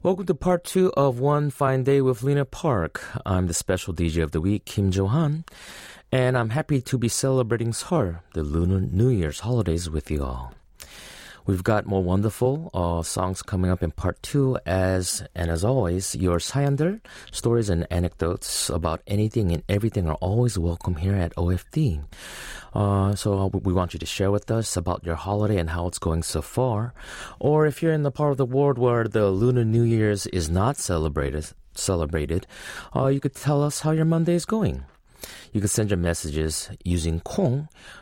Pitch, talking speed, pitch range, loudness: 100 Hz, 185 wpm, 90-130 Hz, -24 LUFS